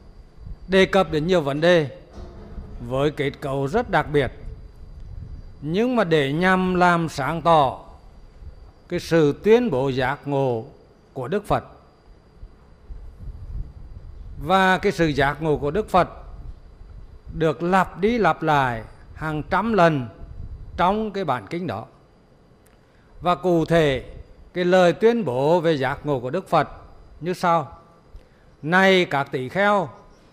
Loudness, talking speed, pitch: -21 LUFS, 135 wpm, 145 Hz